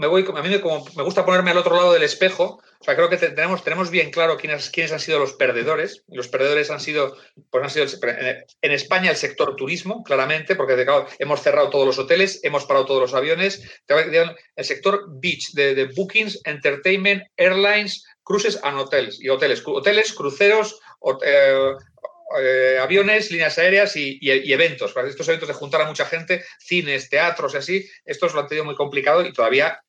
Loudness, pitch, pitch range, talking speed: -19 LUFS, 180 Hz, 150-210 Hz, 200 wpm